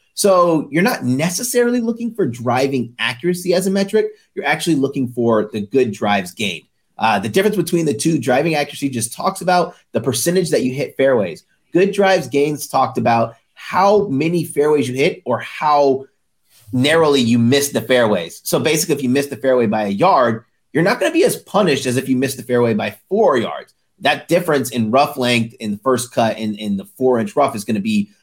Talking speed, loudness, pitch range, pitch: 210 wpm, -17 LUFS, 120-175 Hz, 140 Hz